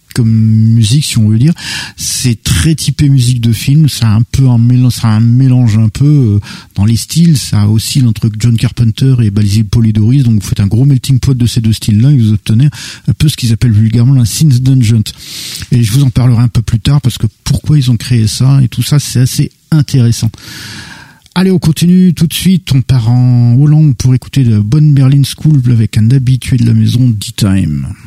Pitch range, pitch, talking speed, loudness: 110-140 Hz, 125 Hz, 220 wpm, -9 LUFS